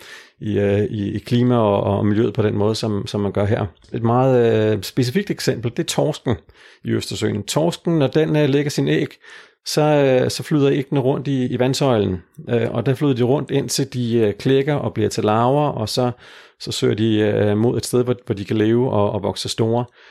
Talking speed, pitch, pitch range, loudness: 220 wpm, 120 Hz, 105-140 Hz, -19 LUFS